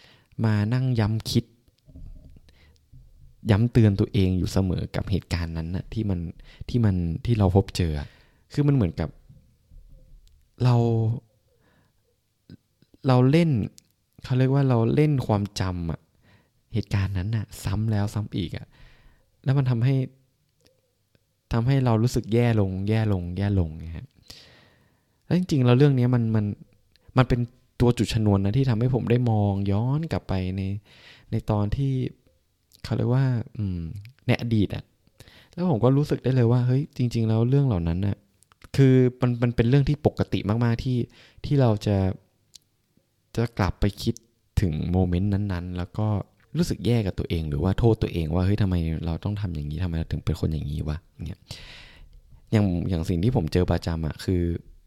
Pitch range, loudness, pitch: 90-120 Hz, -24 LUFS, 105 Hz